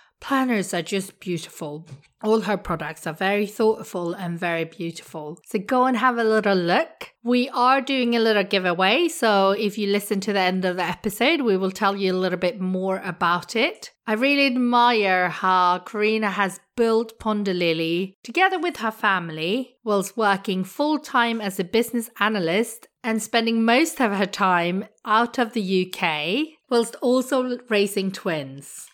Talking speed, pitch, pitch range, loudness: 165 wpm, 205 Hz, 185-235 Hz, -22 LUFS